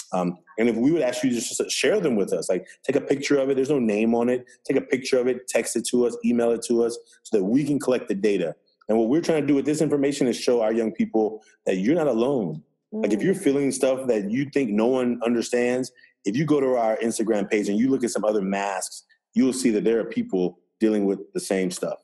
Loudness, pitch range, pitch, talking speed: -23 LUFS, 110-140 Hz, 120 Hz, 265 wpm